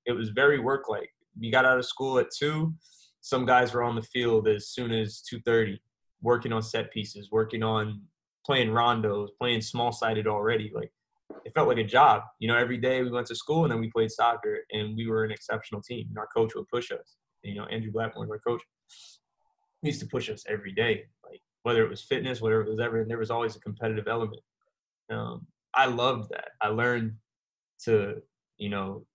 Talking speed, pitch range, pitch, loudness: 210 wpm, 110-125 Hz, 115 Hz, -28 LUFS